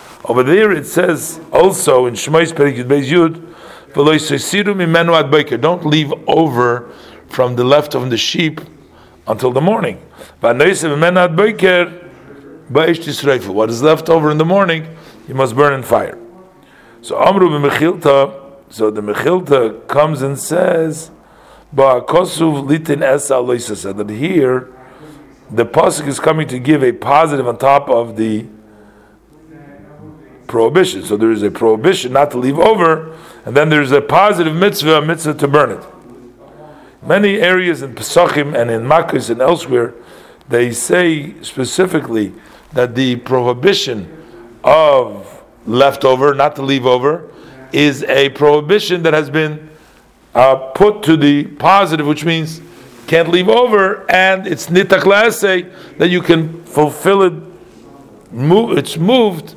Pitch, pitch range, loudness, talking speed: 150 Hz, 130-170 Hz, -13 LUFS, 130 wpm